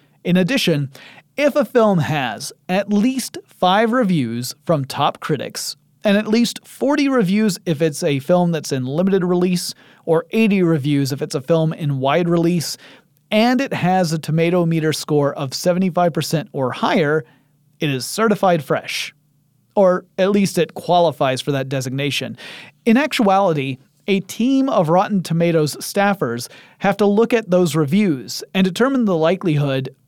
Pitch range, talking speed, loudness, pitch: 150-200 Hz, 155 wpm, -18 LUFS, 175 Hz